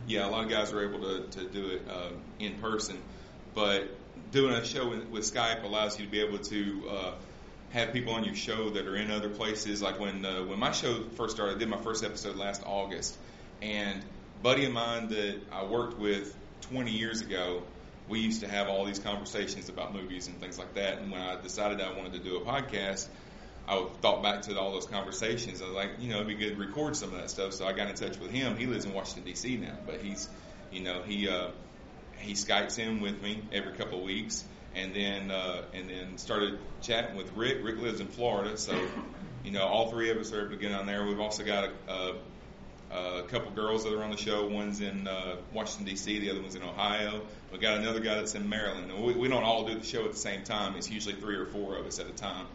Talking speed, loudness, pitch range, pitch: 240 wpm, -33 LUFS, 95-110 Hz, 105 Hz